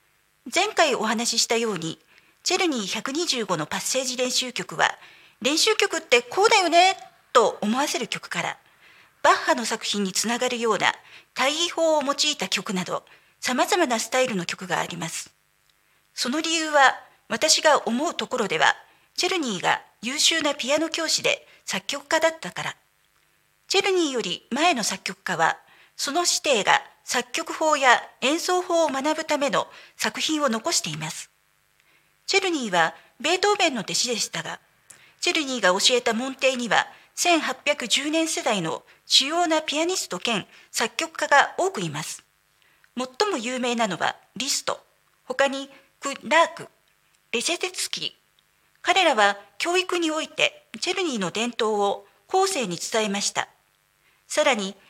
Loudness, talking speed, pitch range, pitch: -23 LUFS, 285 characters per minute, 225-330 Hz, 275 Hz